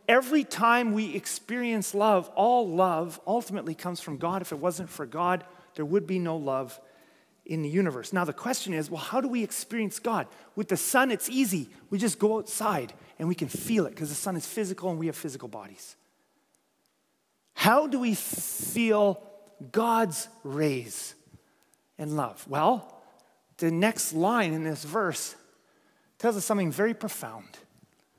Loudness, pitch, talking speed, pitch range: -28 LUFS, 190 Hz, 165 wpm, 160-220 Hz